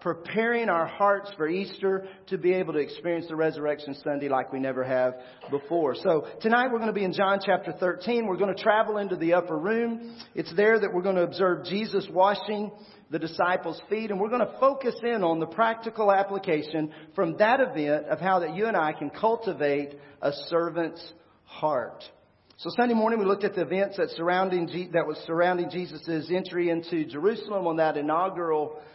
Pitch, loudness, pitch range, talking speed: 180 Hz, -27 LUFS, 160-205 Hz, 190 wpm